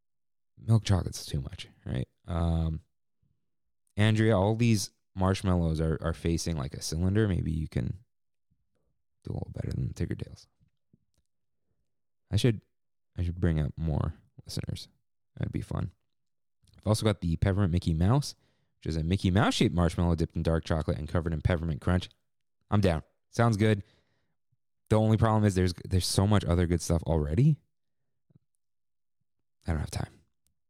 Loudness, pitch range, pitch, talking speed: -29 LUFS, 85-110 Hz, 95 Hz, 155 wpm